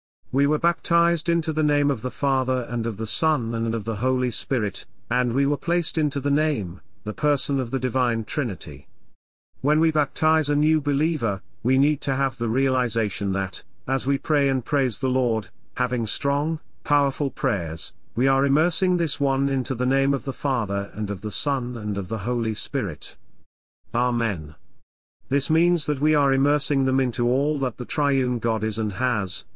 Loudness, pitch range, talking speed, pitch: -24 LUFS, 115-145 Hz, 185 wpm, 130 Hz